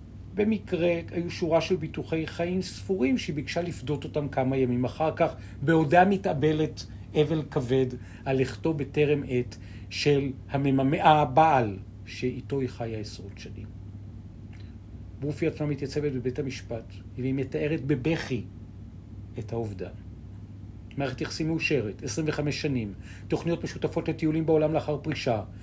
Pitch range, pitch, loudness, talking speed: 105-155 Hz, 135 Hz, -28 LUFS, 120 wpm